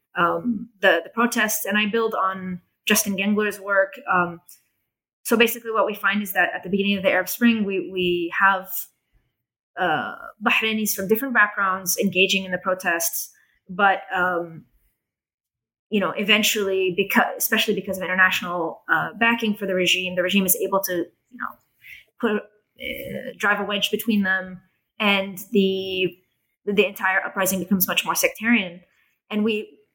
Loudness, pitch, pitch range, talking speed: -21 LUFS, 195 Hz, 185-215 Hz, 155 wpm